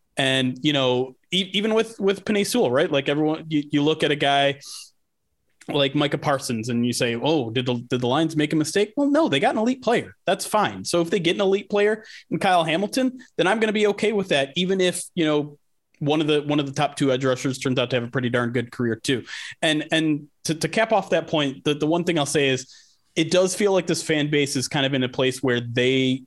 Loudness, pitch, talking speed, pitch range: -22 LUFS, 150 Hz, 260 wpm, 135-185 Hz